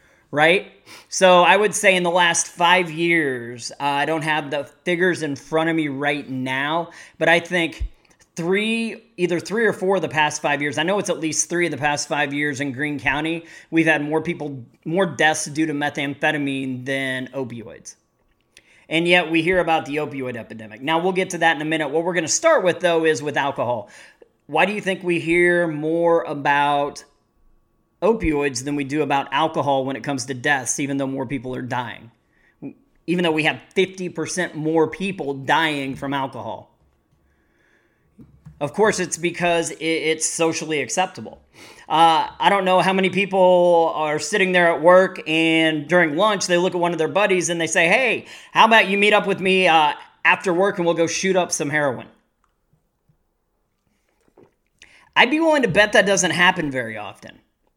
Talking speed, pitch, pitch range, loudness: 190 wpm, 160 Hz, 145-180 Hz, -19 LUFS